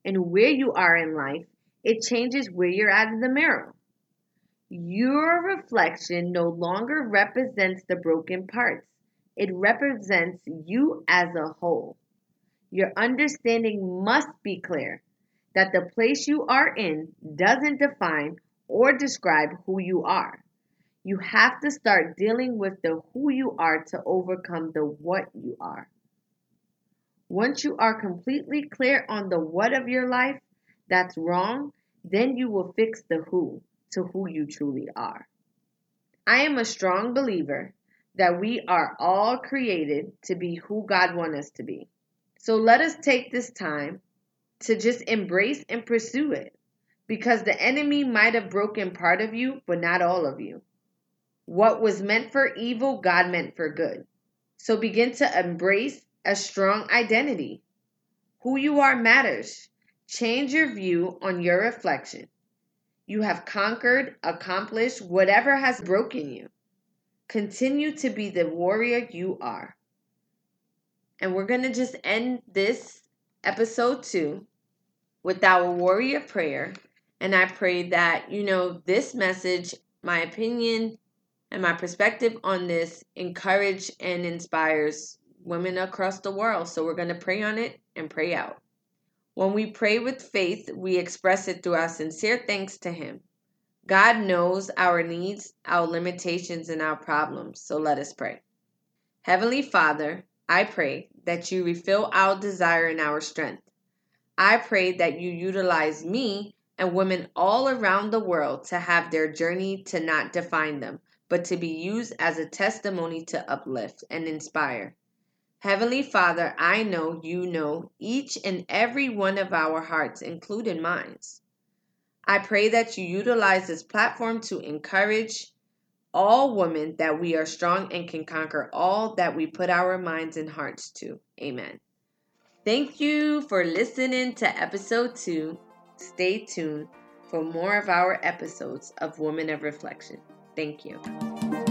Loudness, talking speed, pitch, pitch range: -25 LUFS, 150 wpm, 195 Hz, 175-225 Hz